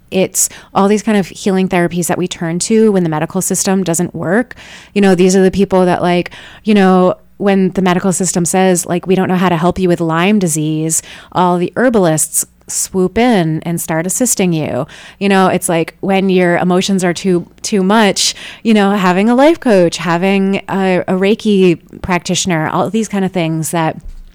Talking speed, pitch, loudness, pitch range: 195 wpm, 185 Hz, -13 LUFS, 170-195 Hz